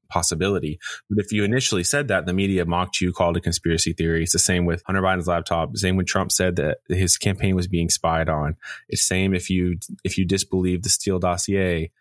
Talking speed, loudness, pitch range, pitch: 220 wpm, -21 LUFS, 85-95 Hz, 90 Hz